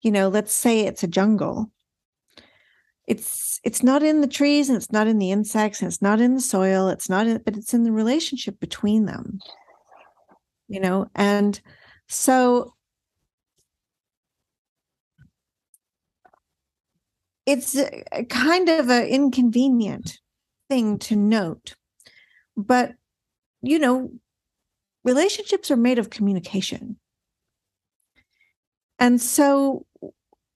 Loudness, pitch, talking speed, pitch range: -21 LUFS, 235 Hz, 110 wpm, 210-260 Hz